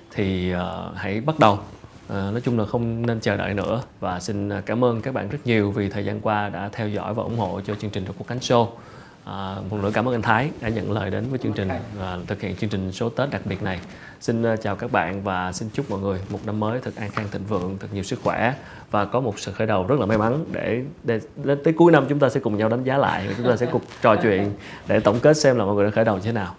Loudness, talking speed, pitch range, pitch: -23 LUFS, 285 wpm, 100-120 Hz, 105 Hz